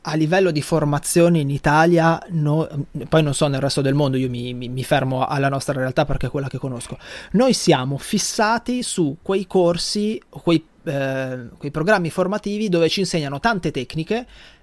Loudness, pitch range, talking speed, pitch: -20 LUFS, 140-180 Hz, 175 wpm, 155 Hz